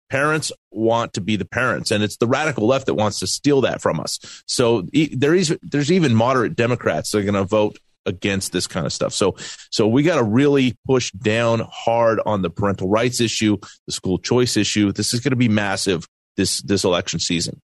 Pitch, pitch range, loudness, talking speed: 115 Hz, 105-130 Hz, -19 LUFS, 215 wpm